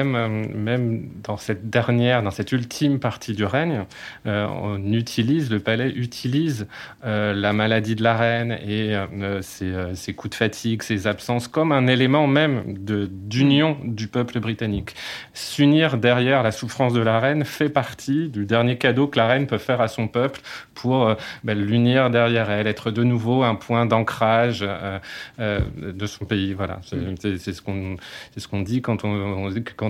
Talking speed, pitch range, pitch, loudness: 185 wpm, 105-125 Hz, 115 Hz, -22 LUFS